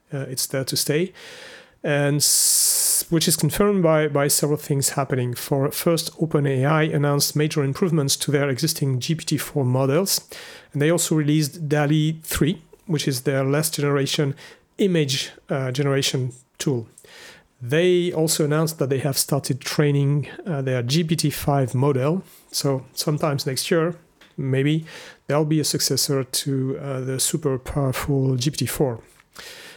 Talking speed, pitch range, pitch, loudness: 135 wpm, 135-160 Hz, 145 Hz, -21 LUFS